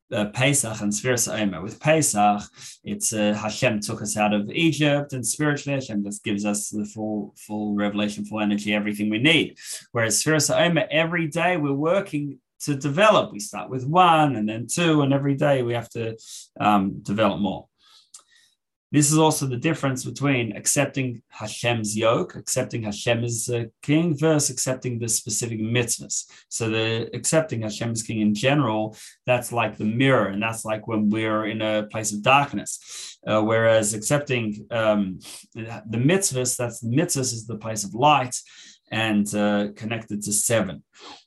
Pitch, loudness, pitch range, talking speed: 115 Hz, -23 LUFS, 105-140 Hz, 165 wpm